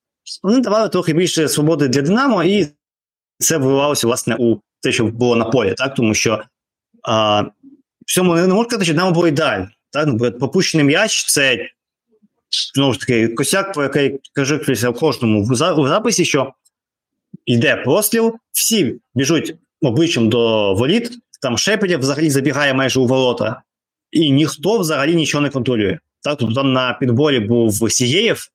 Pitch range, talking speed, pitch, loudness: 120-180 Hz, 150 wpm, 145 Hz, -16 LUFS